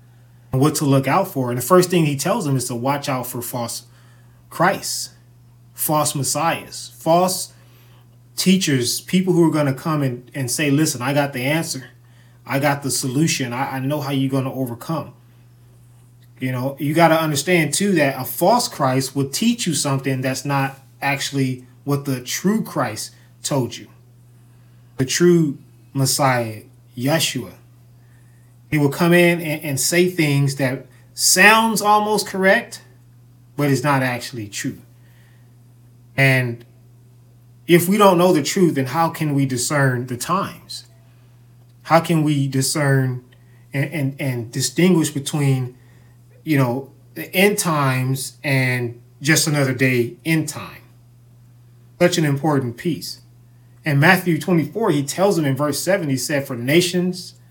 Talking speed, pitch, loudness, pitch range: 150 wpm, 135 Hz, -19 LUFS, 120-155 Hz